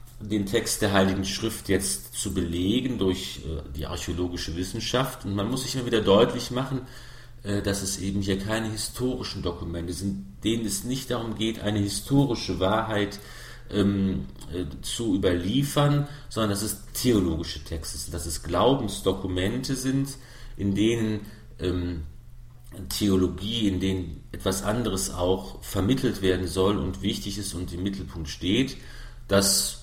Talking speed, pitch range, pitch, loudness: 145 wpm, 95-115 Hz, 100 Hz, -27 LUFS